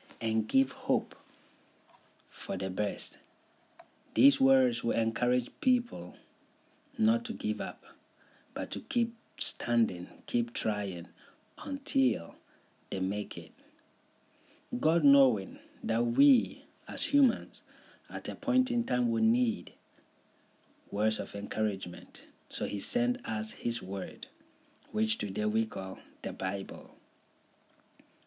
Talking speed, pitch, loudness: 110 wpm, 220 Hz, -31 LUFS